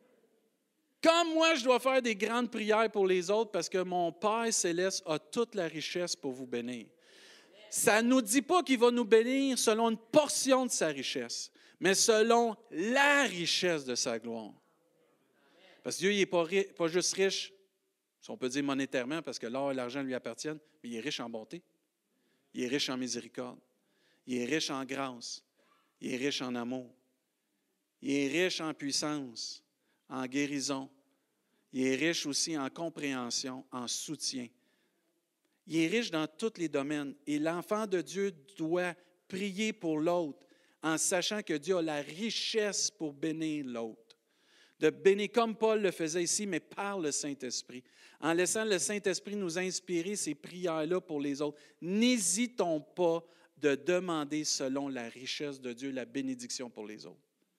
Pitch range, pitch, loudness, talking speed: 140-210 Hz, 170 Hz, -32 LUFS, 170 wpm